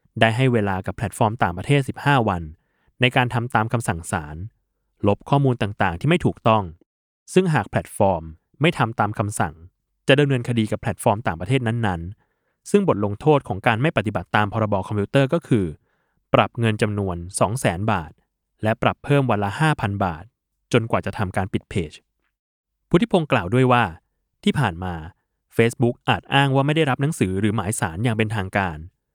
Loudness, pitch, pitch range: -21 LUFS, 110 Hz, 100-130 Hz